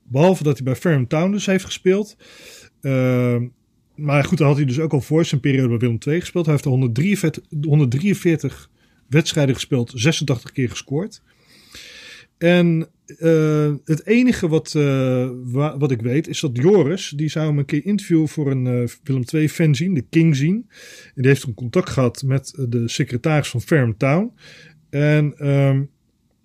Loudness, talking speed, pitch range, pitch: -19 LUFS, 175 wpm, 130-165 Hz, 150 Hz